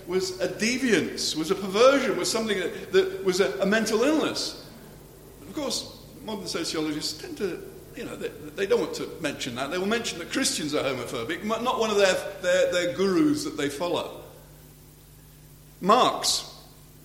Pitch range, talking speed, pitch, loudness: 185-245 Hz, 170 wpm, 195 Hz, -25 LUFS